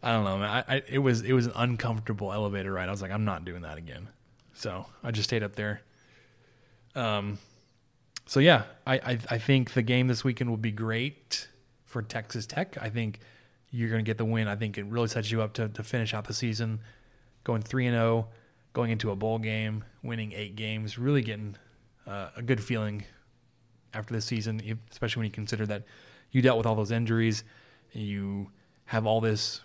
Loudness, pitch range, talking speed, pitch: -30 LUFS, 110-120 Hz, 210 wpm, 115 Hz